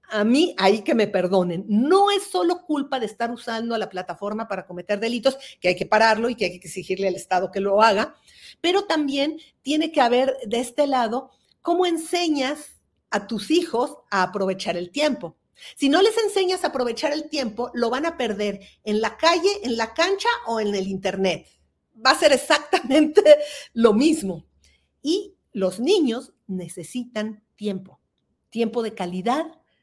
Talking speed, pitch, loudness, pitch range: 170 wpm, 240 Hz, -22 LUFS, 205-300 Hz